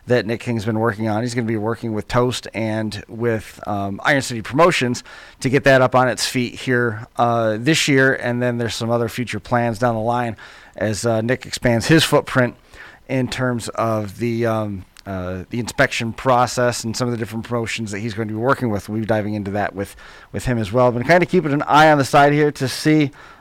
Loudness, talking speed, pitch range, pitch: -19 LUFS, 225 wpm, 110-125 Hz, 120 Hz